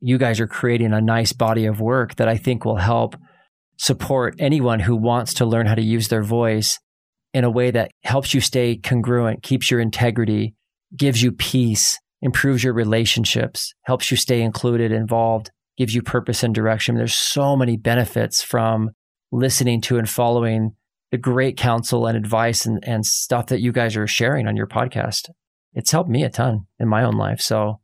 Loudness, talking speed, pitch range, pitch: -19 LUFS, 190 wpm, 110-125 Hz, 115 Hz